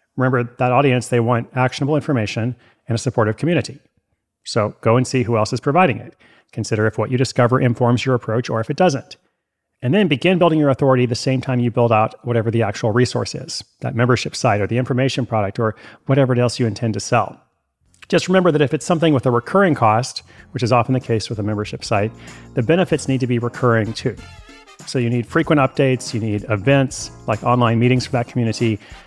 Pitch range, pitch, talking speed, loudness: 115-135 Hz, 125 Hz, 215 wpm, -18 LUFS